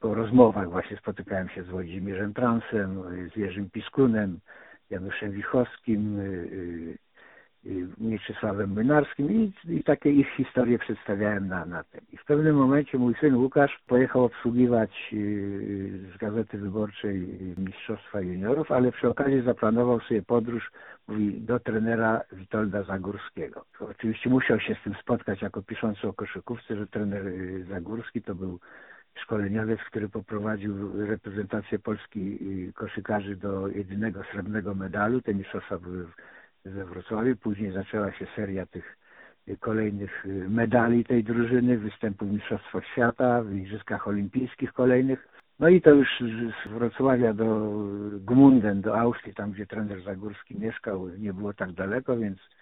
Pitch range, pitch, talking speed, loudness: 100-120 Hz, 105 Hz, 130 wpm, -27 LUFS